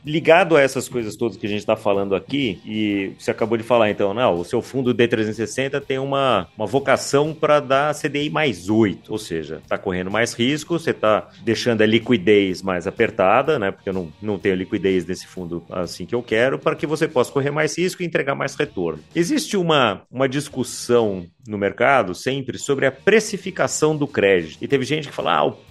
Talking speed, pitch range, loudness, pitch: 205 wpm, 105-145 Hz, -20 LUFS, 120 Hz